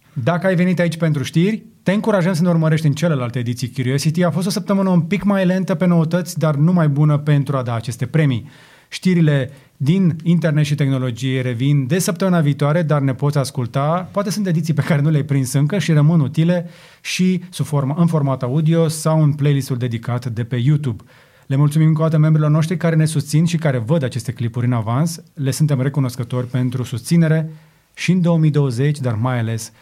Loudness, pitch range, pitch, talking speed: -18 LUFS, 135-170 Hz, 150 Hz, 195 wpm